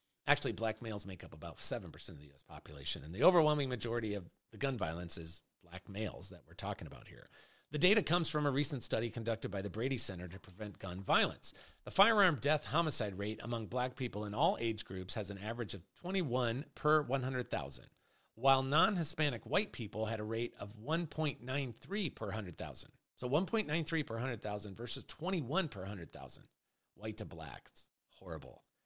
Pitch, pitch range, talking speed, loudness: 115 Hz, 100-145 Hz, 180 wpm, -36 LUFS